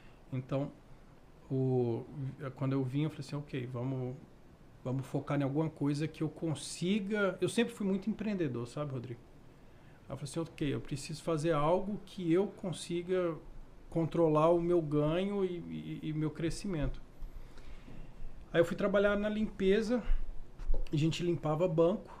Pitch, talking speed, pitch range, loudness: 155 Hz, 145 wpm, 135-180 Hz, -34 LUFS